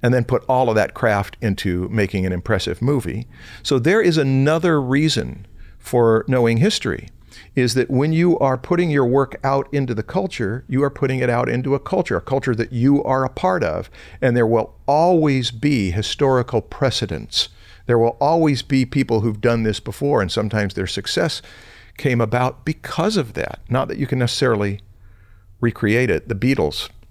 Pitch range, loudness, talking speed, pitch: 110-135 Hz, -19 LUFS, 180 wpm, 125 Hz